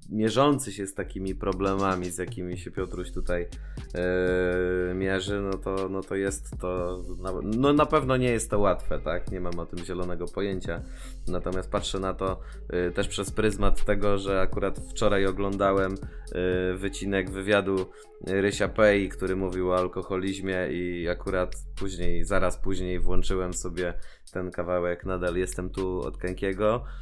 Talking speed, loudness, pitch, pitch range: 155 wpm, -28 LUFS, 95 Hz, 90-100 Hz